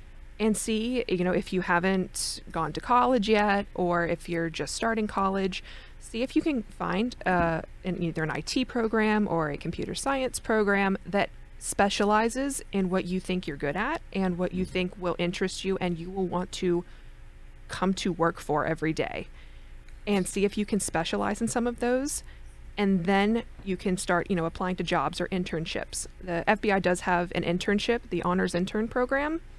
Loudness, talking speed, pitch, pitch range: -28 LUFS, 185 wpm, 190 Hz, 175-215 Hz